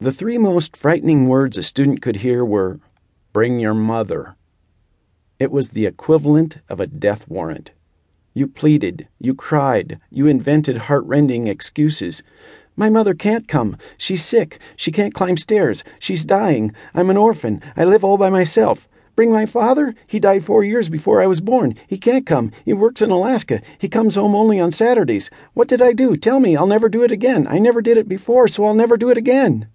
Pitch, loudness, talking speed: 180 Hz, -16 LUFS, 190 wpm